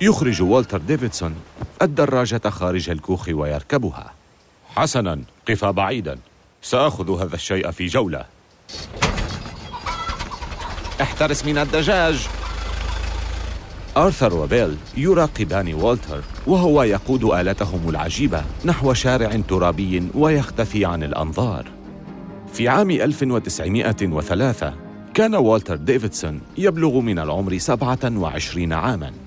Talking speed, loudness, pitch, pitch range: 90 wpm, -20 LUFS, 100 Hz, 85-125 Hz